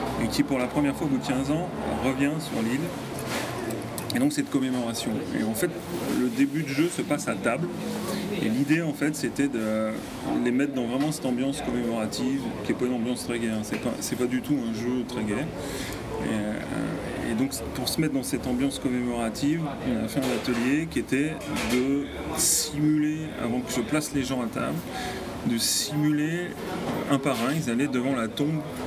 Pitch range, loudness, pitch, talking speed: 120-150 Hz, -27 LUFS, 135 Hz, 200 wpm